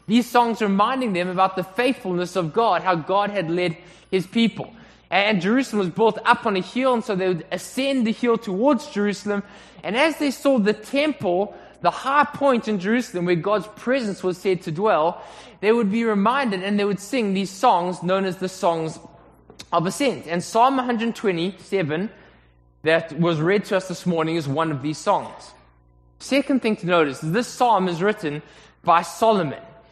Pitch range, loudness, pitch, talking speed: 175-230 Hz, -22 LUFS, 195 Hz, 185 wpm